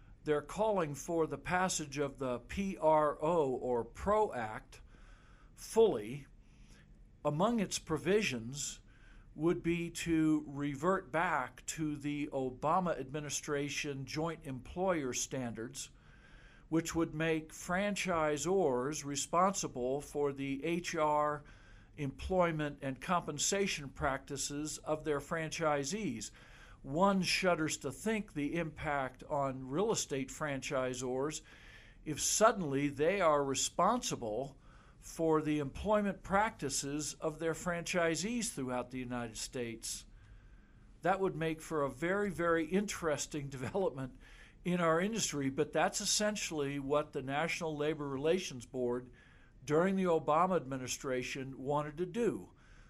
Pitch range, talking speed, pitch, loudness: 135-170 Hz, 110 wpm, 150 Hz, -35 LUFS